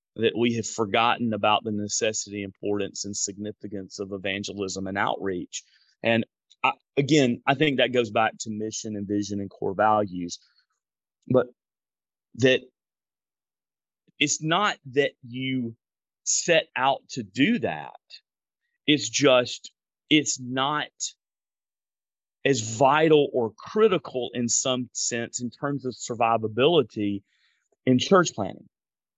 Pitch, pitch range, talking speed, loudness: 115 Hz, 105-135 Hz, 120 wpm, -25 LUFS